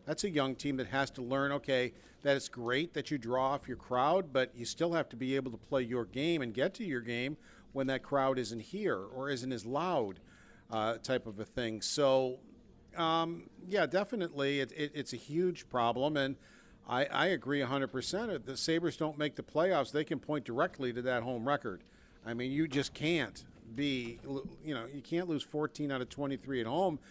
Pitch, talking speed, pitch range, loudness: 135 Hz, 210 wpm, 125-150 Hz, -35 LUFS